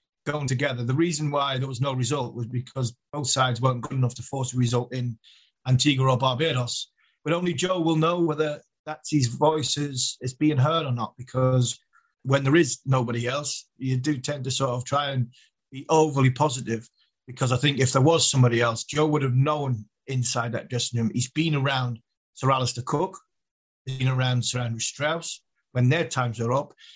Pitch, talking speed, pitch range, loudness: 130 Hz, 195 wpm, 125-145 Hz, -25 LUFS